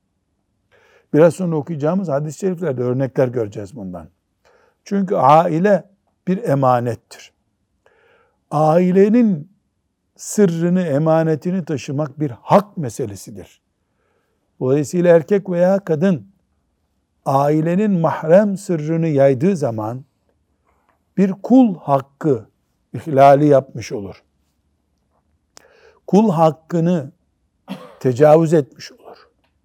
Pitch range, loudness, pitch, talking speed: 110-175 Hz, -17 LUFS, 150 Hz, 80 wpm